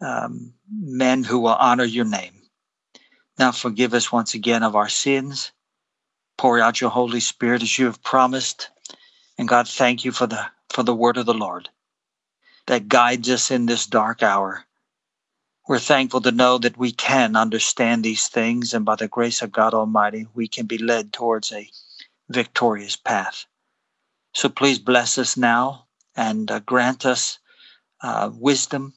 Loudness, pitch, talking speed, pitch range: -20 LUFS, 120 Hz, 165 wpm, 115-125 Hz